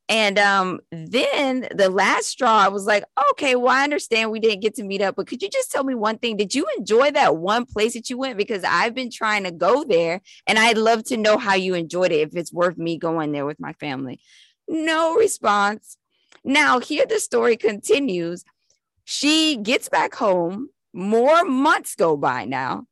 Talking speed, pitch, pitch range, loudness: 200 wpm, 220 Hz, 195-280 Hz, -20 LUFS